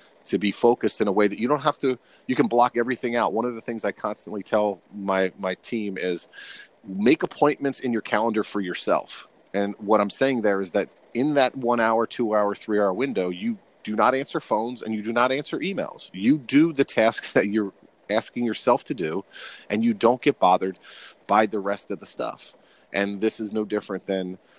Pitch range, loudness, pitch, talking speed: 100-125 Hz, -24 LUFS, 110 Hz, 215 wpm